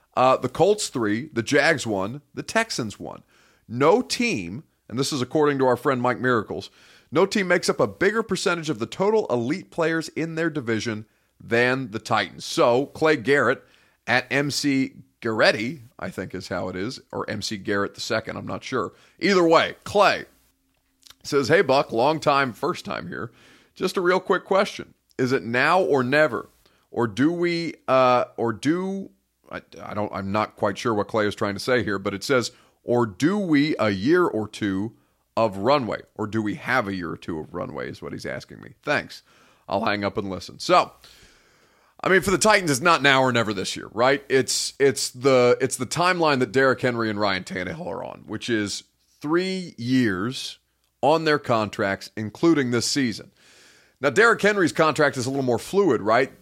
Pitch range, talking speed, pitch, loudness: 110-155 Hz, 190 wpm, 130 Hz, -23 LUFS